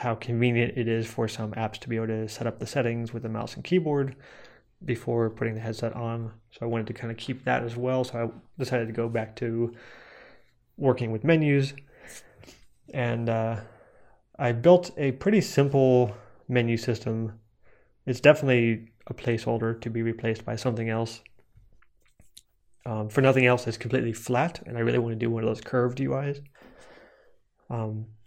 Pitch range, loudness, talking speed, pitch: 115-125 Hz, -27 LUFS, 175 wpm, 115 Hz